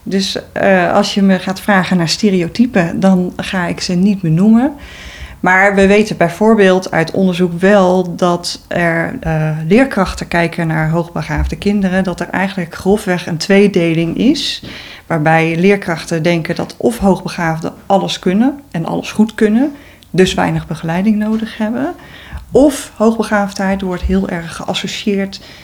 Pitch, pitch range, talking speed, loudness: 190 Hz, 170-205 Hz, 145 wpm, -14 LUFS